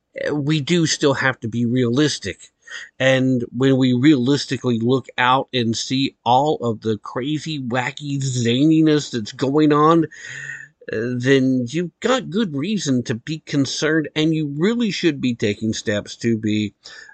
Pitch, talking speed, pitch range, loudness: 135 Hz, 145 wpm, 120-155 Hz, -19 LUFS